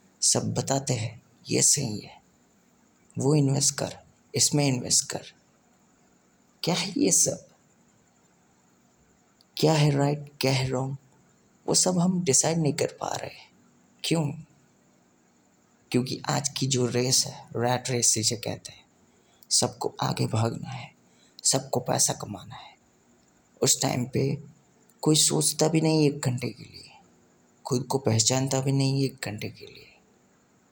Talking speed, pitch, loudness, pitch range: 140 wpm, 135 Hz, -25 LUFS, 120-145 Hz